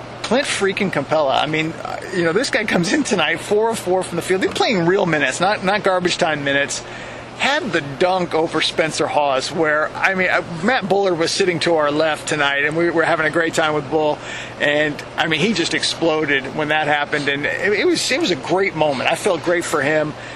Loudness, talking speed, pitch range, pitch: -18 LUFS, 220 wpm, 150-185 Hz, 160 Hz